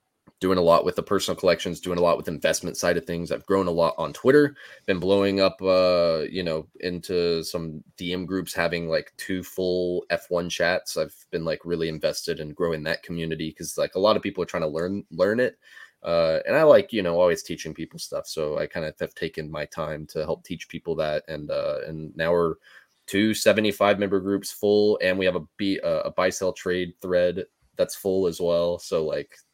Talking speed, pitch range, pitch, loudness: 215 wpm, 85-100 Hz, 90 Hz, -25 LUFS